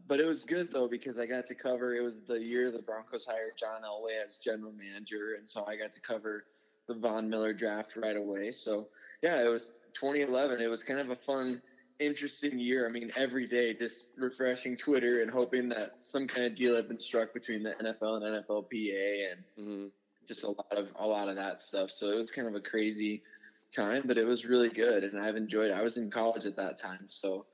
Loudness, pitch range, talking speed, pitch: -34 LUFS, 105-125 Hz, 225 wpm, 115 Hz